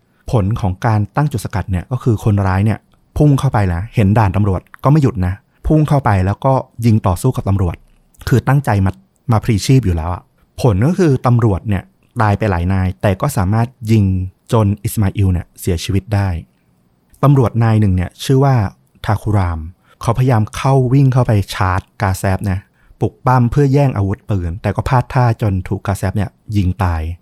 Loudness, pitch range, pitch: -15 LUFS, 95-125 Hz, 105 Hz